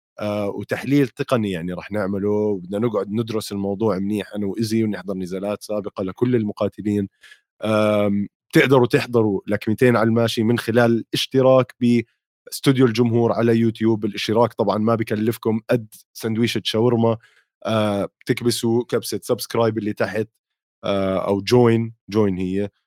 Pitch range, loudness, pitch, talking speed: 105-120 Hz, -21 LUFS, 110 Hz, 120 wpm